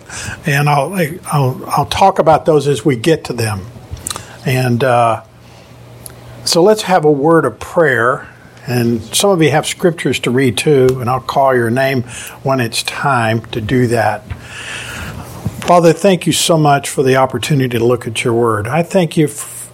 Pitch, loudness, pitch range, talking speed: 130 Hz, -13 LUFS, 120-155 Hz, 175 wpm